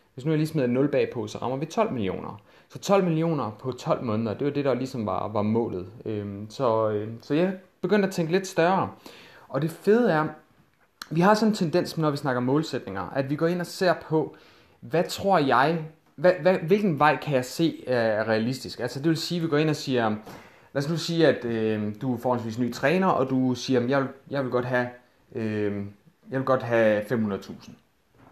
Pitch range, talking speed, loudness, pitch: 115-165 Hz, 210 wpm, -25 LUFS, 135 Hz